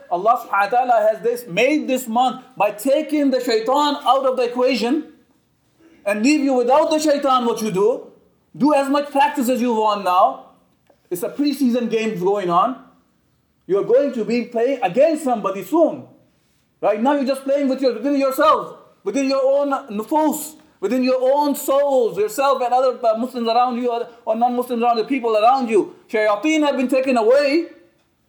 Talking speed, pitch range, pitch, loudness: 180 wpm, 235-290 Hz, 260 Hz, -18 LUFS